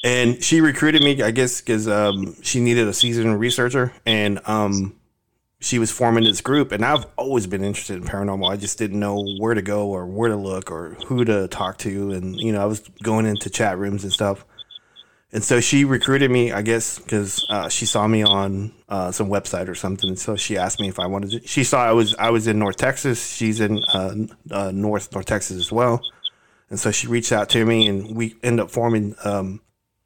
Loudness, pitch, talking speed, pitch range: -20 LUFS, 110 Hz, 225 wpm, 100-115 Hz